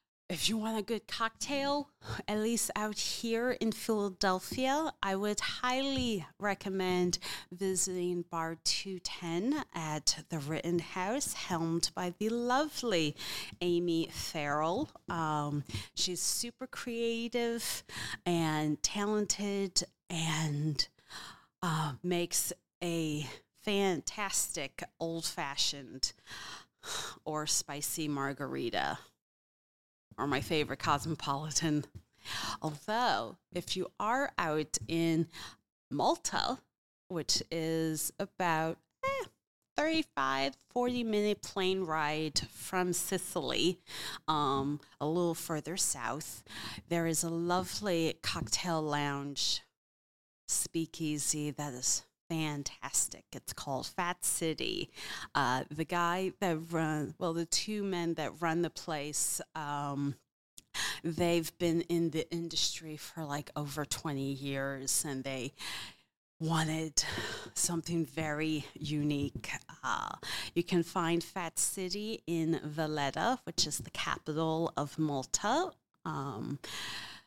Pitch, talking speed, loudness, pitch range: 165 Hz, 100 wpm, -34 LUFS, 150-185 Hz